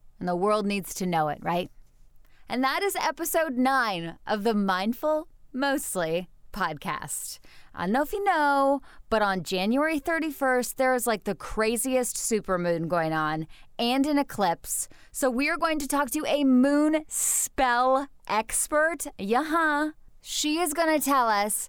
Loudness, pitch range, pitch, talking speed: -26 LUFS, 205-300 Hz, 260 Hz, 160 wpm